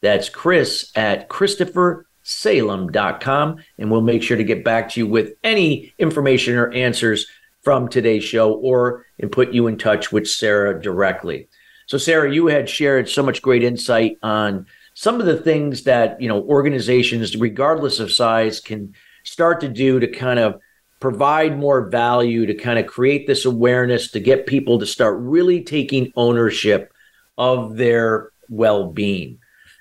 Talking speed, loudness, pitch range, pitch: 155 wpm, -18 LUFS, 110-140 Hz, 120 Hz